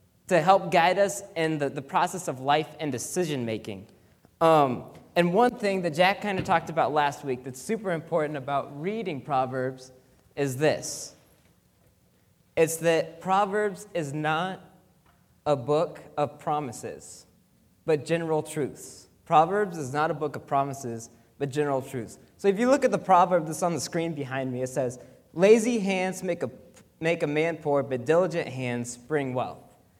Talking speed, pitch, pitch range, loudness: 165 wpm, 155 Hz, 140-180 Hz, -26 LUFS